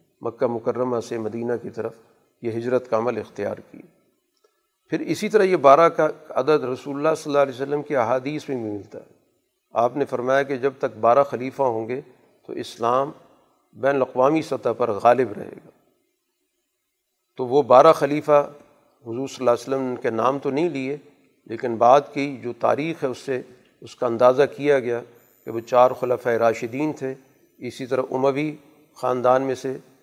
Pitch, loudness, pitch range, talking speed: 135 Hz, -22 LUFS, 125-150 Hz, 180 wpm